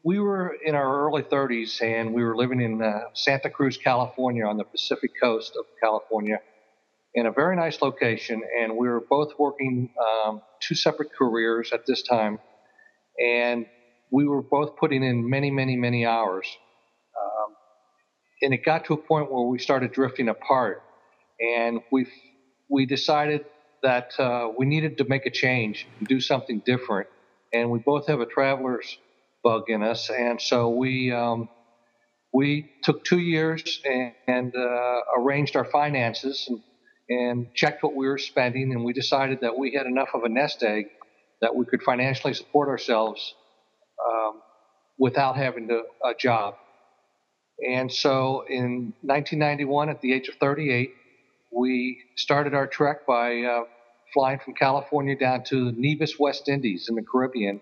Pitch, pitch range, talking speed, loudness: 130 Hz, 115-140 Hz, 160 wpm, -25 LUFS